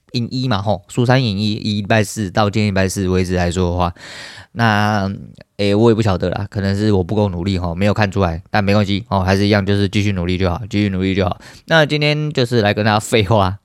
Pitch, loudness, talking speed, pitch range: 105 Hz, -17 LUFS, 350 characters per minute, 95-110 Hz